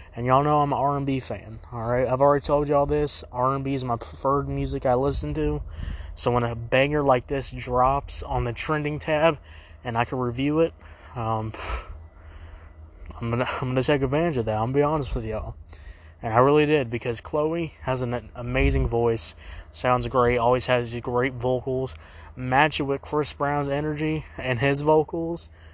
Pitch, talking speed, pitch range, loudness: 125 Hz, 185 wpm, 110-140 Hz, -24 LUFS